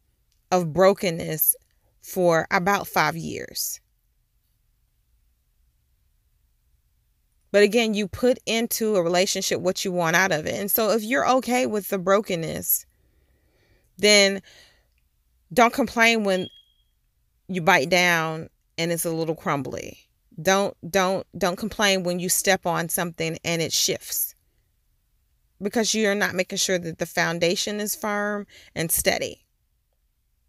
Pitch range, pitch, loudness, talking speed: 160-205 Hz, 185 Hz, -22 LUFS, 125 wpm